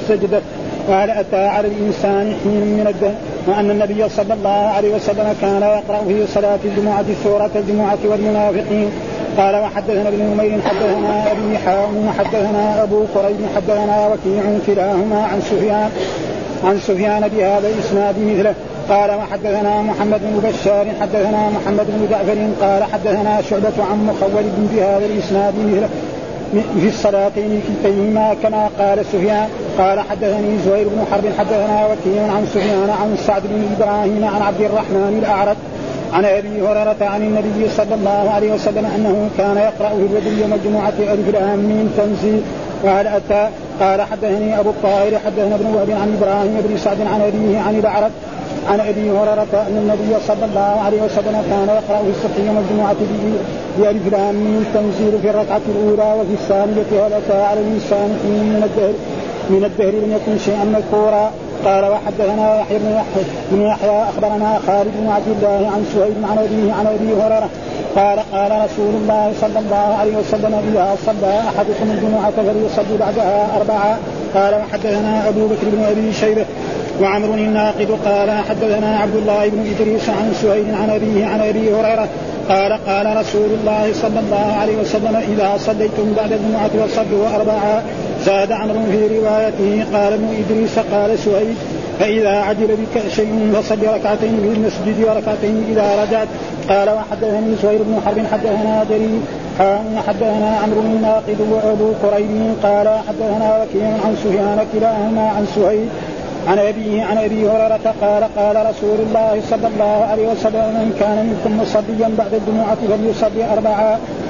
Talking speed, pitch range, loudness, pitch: 150 wpm, 205-215 Hz, -16 LUFS, 210 Hz